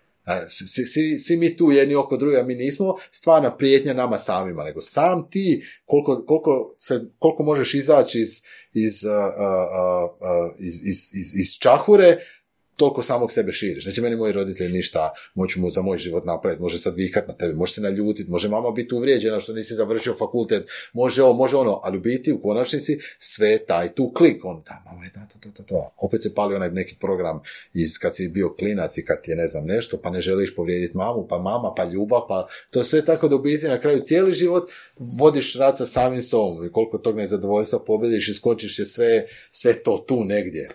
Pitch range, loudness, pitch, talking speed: 95-150 Hz, -21 LUFS, 120 Hz, 200 wpm